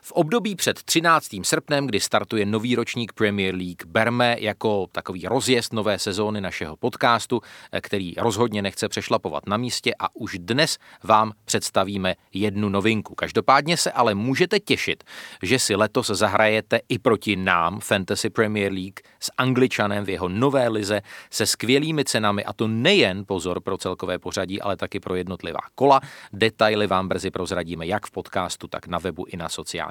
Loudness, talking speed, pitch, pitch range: -23 LUFS, 165 wpm, 105 Hz, 95-120 Hz